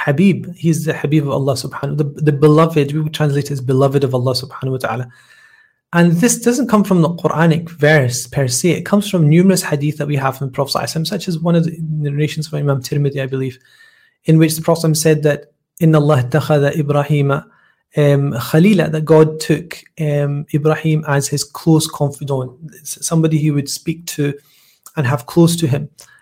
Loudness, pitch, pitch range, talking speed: -15 LUFS, 150 Hz, 140-165 Hz, 185 wpm